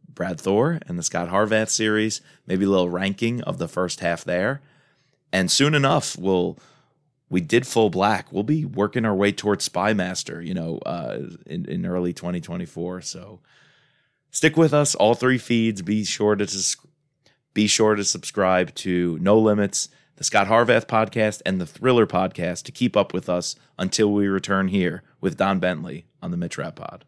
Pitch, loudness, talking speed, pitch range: 105 Hz, -22 LUFS, 175 wpm, 95-130 Hz